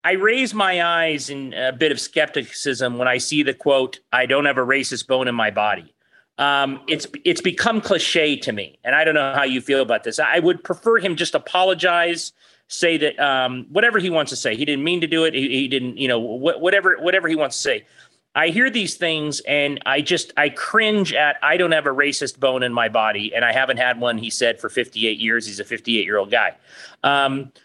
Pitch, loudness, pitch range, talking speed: 145 Hz, -19 LUFS, 130-170 Hz, 235 wpm